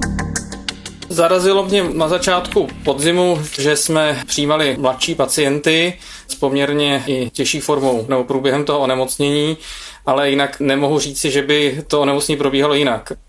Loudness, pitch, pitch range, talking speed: -16 LUFS, 145 Hz, 140-160 Hz, 135 wpm